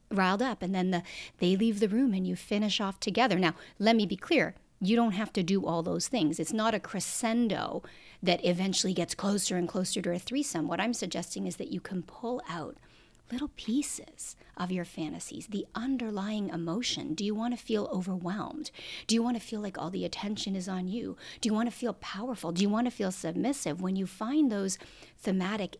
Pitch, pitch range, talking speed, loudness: 200 Hz, 185-230 Hz, 215 wpm, -31 LUFS